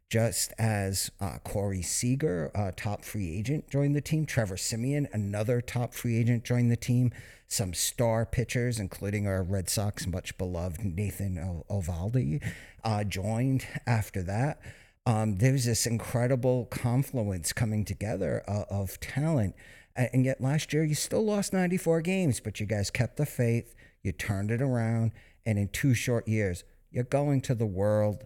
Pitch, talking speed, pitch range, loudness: 115 Hz, 160 wpm, 100-130 Hz, -30 LUFS